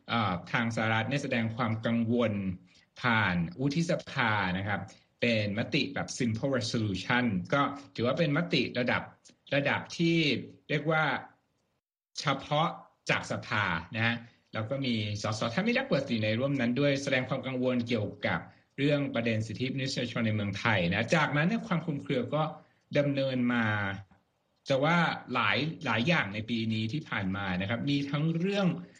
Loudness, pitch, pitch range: -30 LUFS, 120 Hz, 110-145 Hz